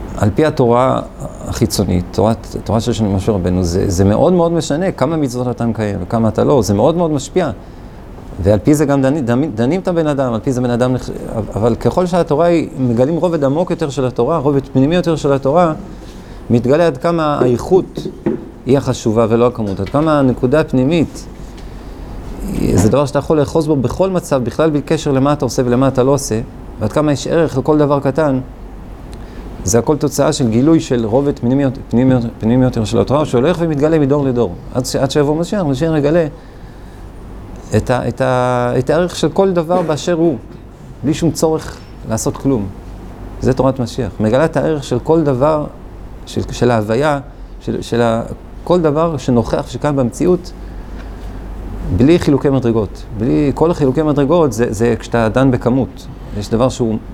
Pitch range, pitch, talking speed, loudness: 115-150 Hz, 130 Hz, 175 wpm, -15 LUFS